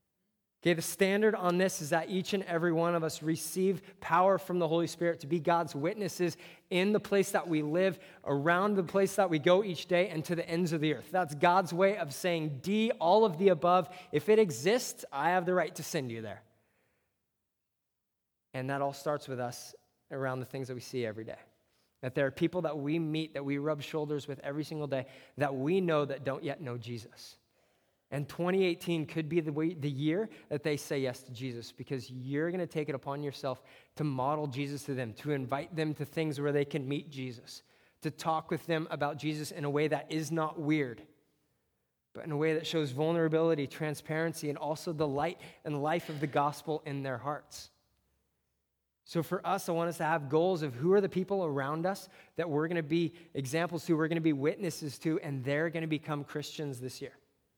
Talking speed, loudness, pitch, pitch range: 220 wpm, -32 LUFS, 155 Hz, 140-170 Hz